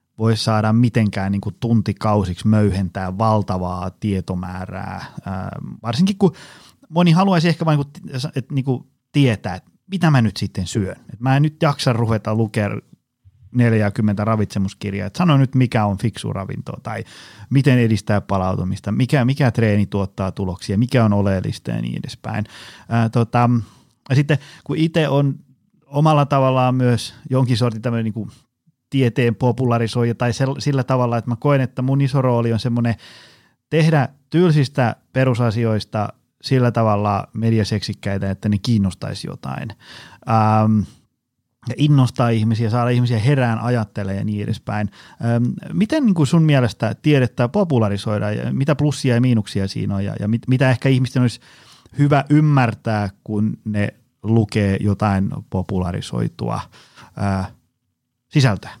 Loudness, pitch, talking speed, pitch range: -19 LUFS, 115 Hz, 135 wpm, 105-130 Hz